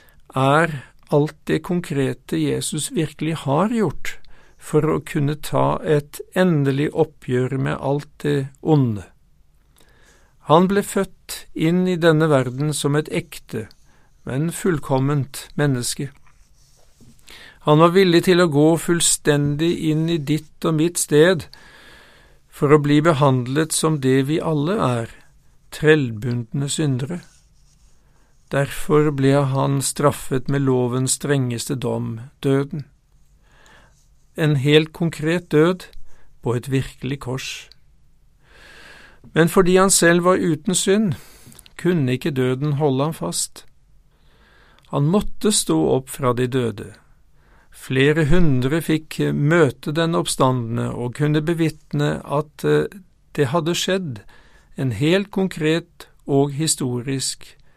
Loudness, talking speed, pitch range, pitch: -20 LUFS, 115 wpm, 135-165 Hz, 150 Hz